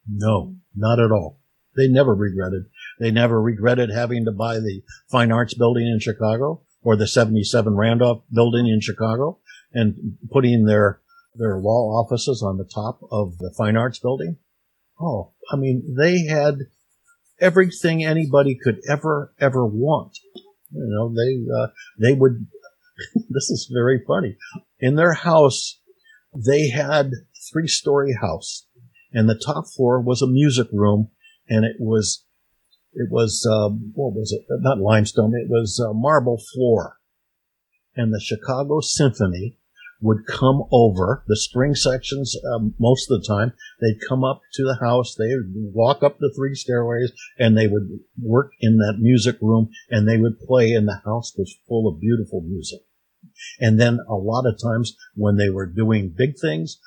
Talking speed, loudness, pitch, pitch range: 160 wpm, -20 LUFS, 120 Hz, 110-135 Hz